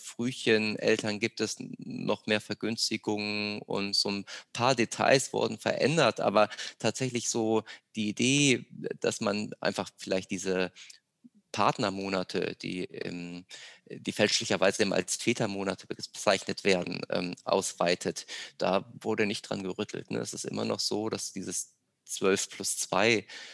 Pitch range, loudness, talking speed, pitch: 95-115 Hz, -30 LUFS, 125 wpm, 105 Hz